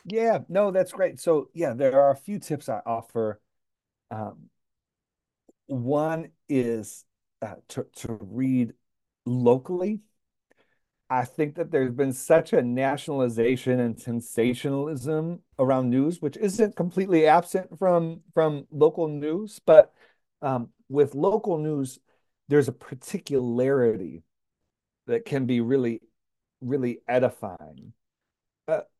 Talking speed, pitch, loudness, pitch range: 115 wpm, 145 Hz, -25 LUFS, 125-175 Hz